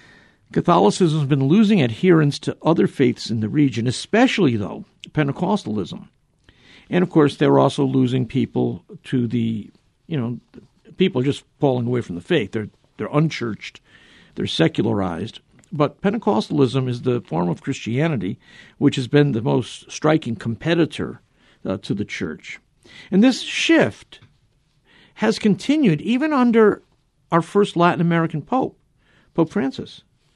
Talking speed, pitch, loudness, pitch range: 135 wpm, 150 Hz, -20 LUFS, 125-190 Hz